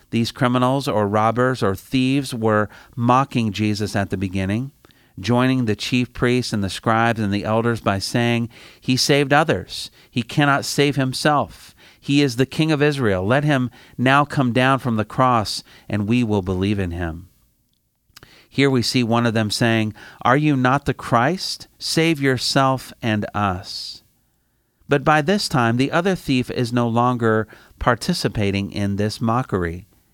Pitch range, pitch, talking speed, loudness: 105-135 Hz, 120 Hz, 160 wpm, -20 LUFS